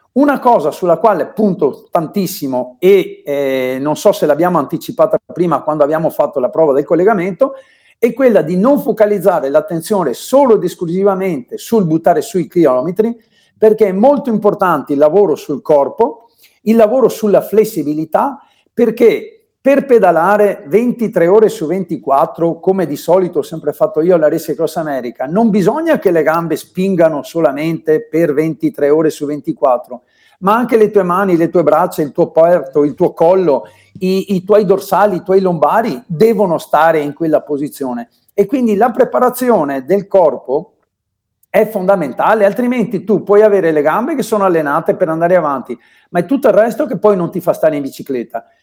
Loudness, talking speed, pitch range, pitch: -13 LUFS, 165 wpm, 160-220 Hz, 190 Hz